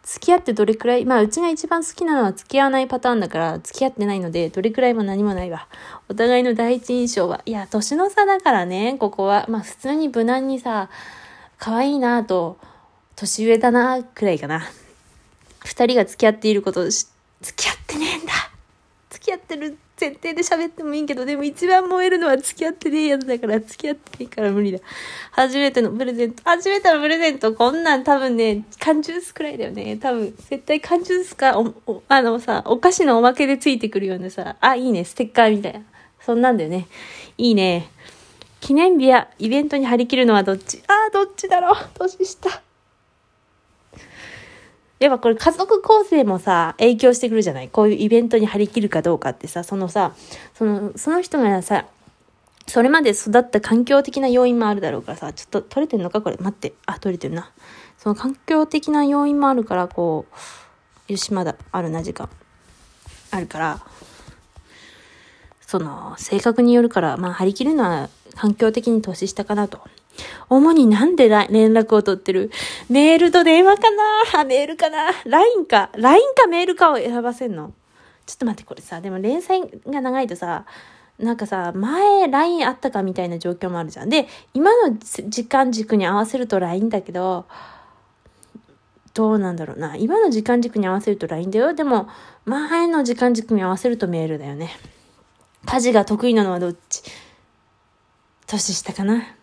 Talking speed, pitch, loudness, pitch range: 345 characters per minute, 240 Hz, -18 LUFS, 205-295 Hz